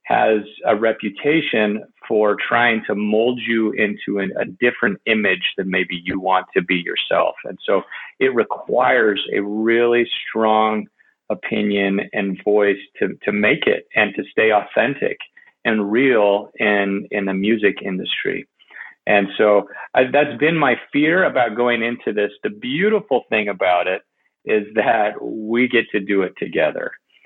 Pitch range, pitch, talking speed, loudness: 100-120 Hz, 105 Hz, 150 wpm, -18 LUFS